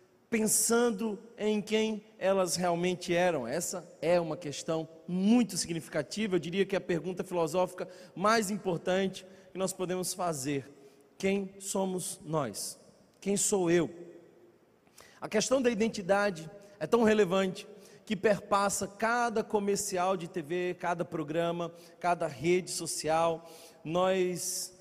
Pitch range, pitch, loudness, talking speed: 170-200 Hz, 185 Hz, -31 LUFS, 120 wpm